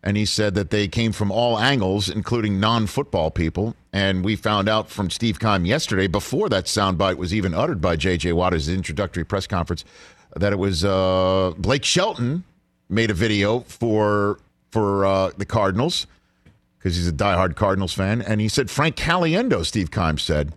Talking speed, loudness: 175 wpm, -21 LUFS